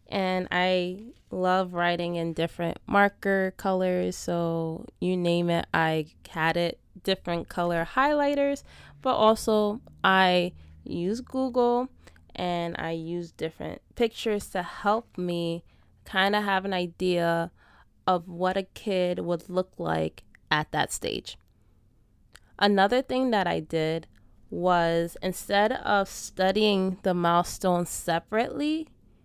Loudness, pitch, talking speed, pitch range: -27 LUFS, 180 Hz, 120 wpm, 170-200 Hz